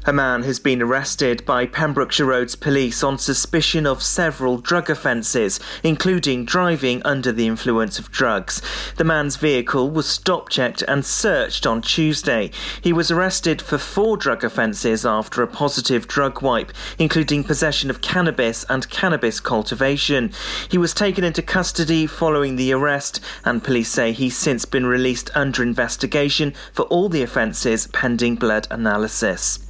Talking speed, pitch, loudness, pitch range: 150 wpm, 140 Hz, -19 LUFS, 125-160 Hz